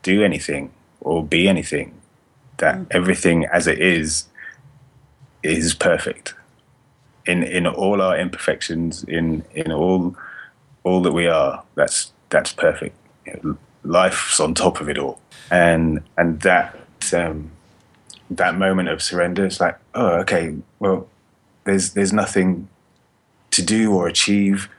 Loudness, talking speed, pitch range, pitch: -19 LUFS, 130 wpm, 85-100 Hz, 90 Hz